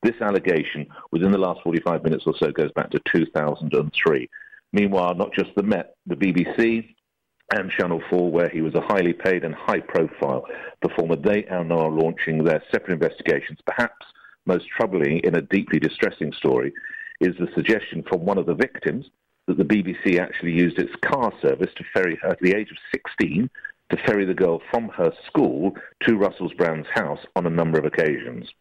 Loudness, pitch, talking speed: -22 LUFS, 95 Hz, 180 wpm